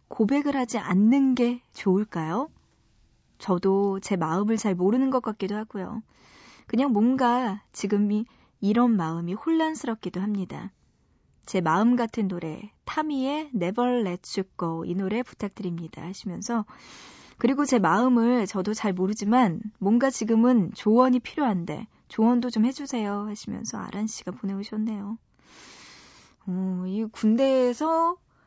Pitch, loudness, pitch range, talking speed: 215 Hz, -25 LUFS, 195-245 Hz, 275 characters per minute